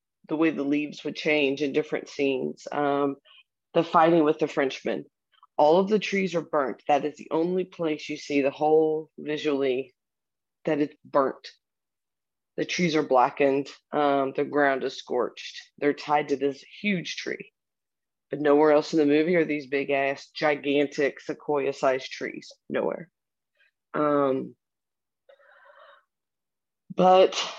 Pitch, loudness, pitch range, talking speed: 150 Hz, -25 LUFS, 140-160 Hz, 145 wpm